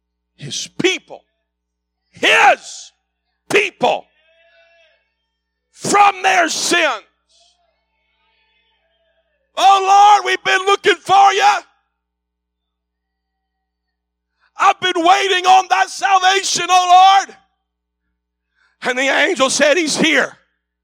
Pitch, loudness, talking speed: 300 Hz, -13 LUFS, 80 wpm